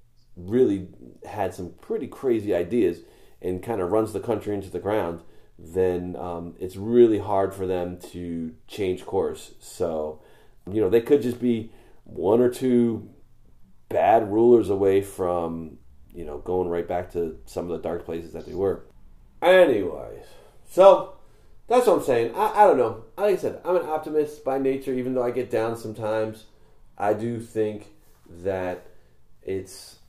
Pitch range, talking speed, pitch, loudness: 90-120 Hz, 165 wpm, 105 Hz, -24 LUFS